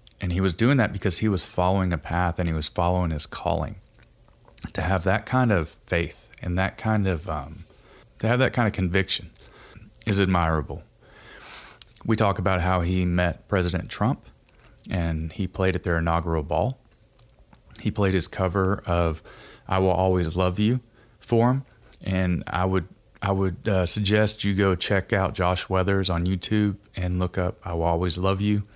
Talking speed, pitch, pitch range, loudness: 180 wpm, 95 Hz, 90-105 Hz, -24 LUFS